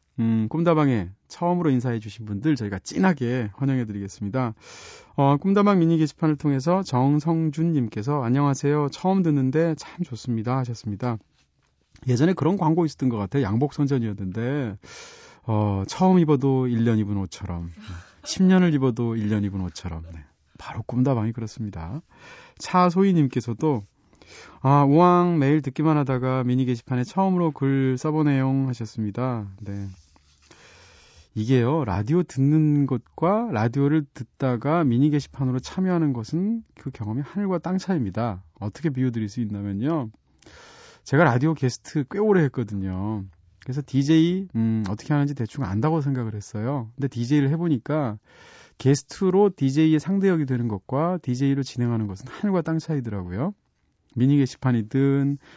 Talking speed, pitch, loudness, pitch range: 335 characters per minute, 135 Hz, -23 LUFS, 110-155 Hz